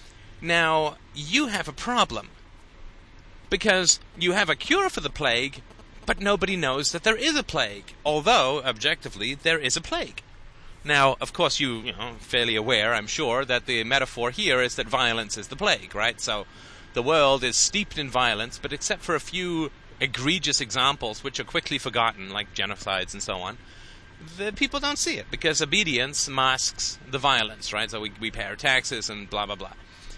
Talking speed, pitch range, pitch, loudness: 185 wpm, 105-155 Hz, 130 Hz, -24 LUFS